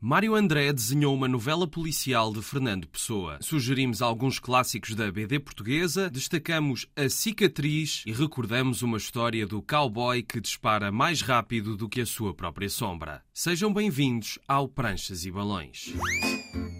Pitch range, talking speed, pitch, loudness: 110-145 Hz, 145 wpm, 125 Hz, -27 LUFS